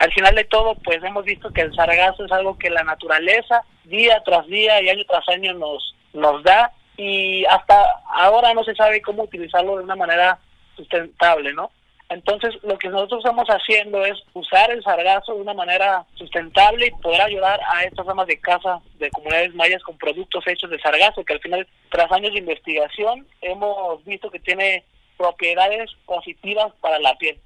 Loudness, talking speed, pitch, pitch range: -18 LUFS, 185 wpm, 190 Hz, 170-210 Hz